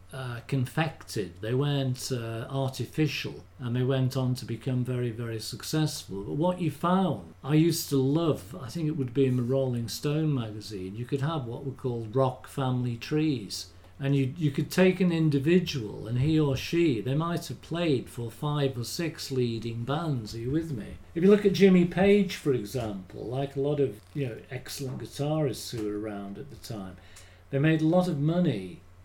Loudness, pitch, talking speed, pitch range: -28 LUFS, 135 Hz, 195 wpm, 115-155 Hz